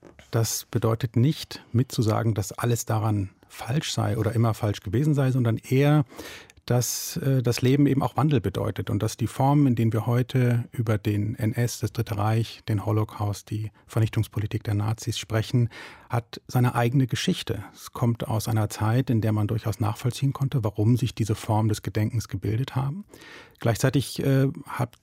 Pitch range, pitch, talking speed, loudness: 110-130 Hz, 115 Hz, 170 wpm, -25 LUFS